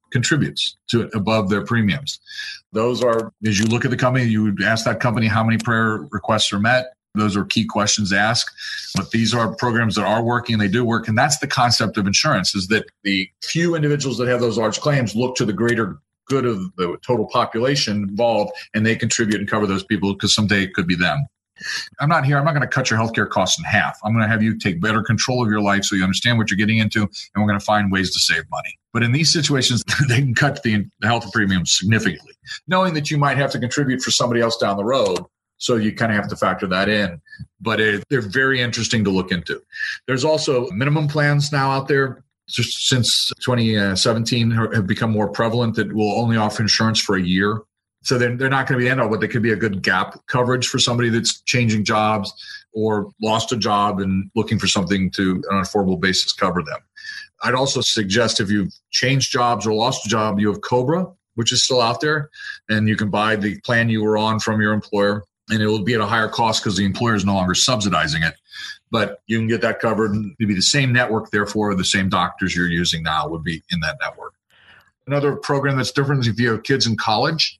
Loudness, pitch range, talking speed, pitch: -19 LUFS, 105-125 Hz, 235 wpm, 115 Hz